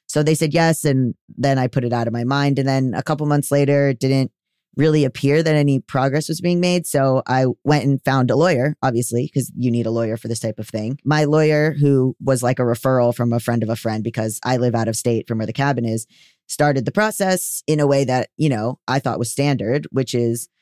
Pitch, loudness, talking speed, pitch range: 135 Hz, -19 LUFS, 250 wpm, 120-145 Hz